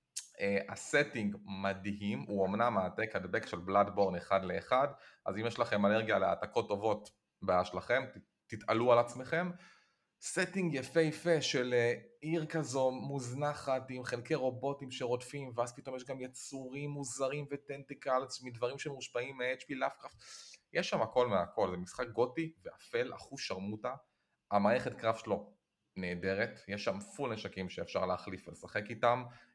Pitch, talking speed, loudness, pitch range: 125 Hz, 140 wpm, -36 LUFS, 100-140 Hz